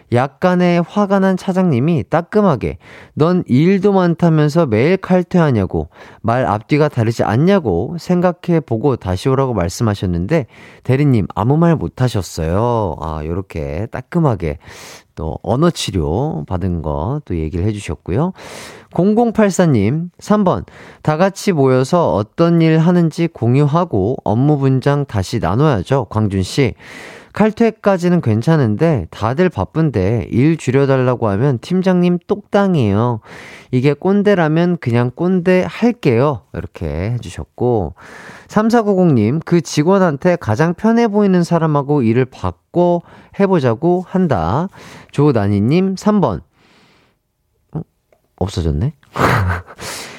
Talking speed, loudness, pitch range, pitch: 245 characters per minute, -15 LUFS, 110-175 Hz, 145 Hz